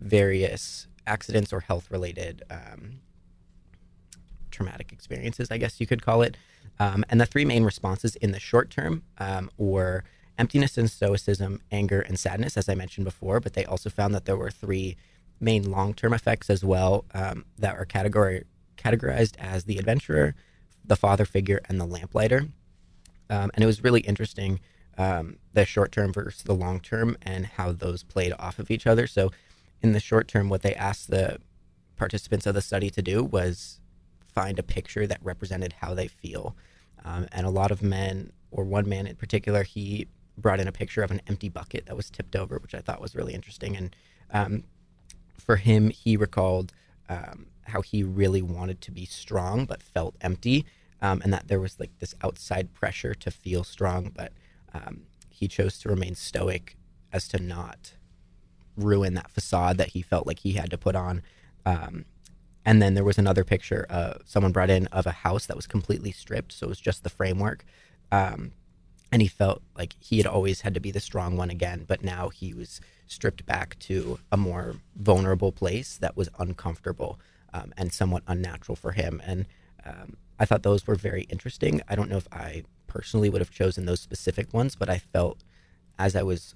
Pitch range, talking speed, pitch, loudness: 90-105 Hz, 190 wpm, 95 Hz, -27 LUFS